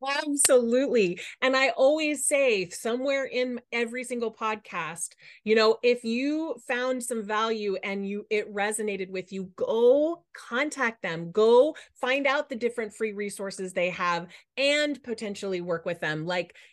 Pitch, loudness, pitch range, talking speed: 230 Hz, -26 LUFS, 200-265 Hz, 145 wpm